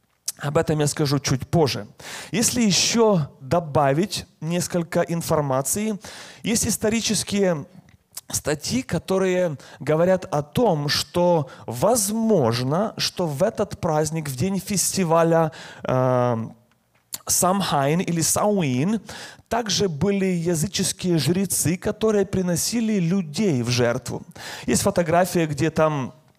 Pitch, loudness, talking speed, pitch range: 170 Hz, -22 LUFS, 100 wpm, 150-195 Hz